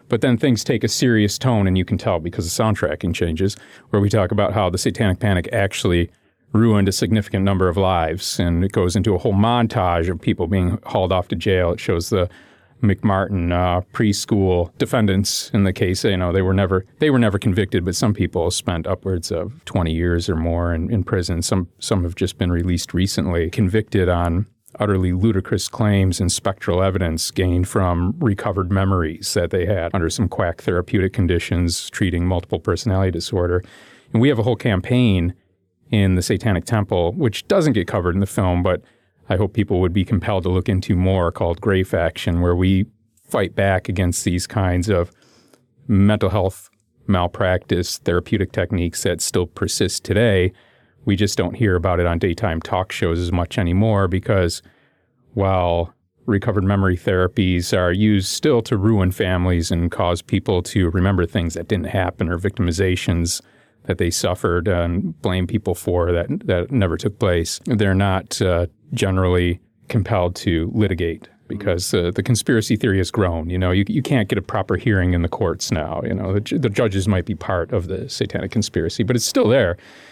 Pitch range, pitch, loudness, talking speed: 90-105 Hz, 95 Hz, -20 LUFS, 185 wpm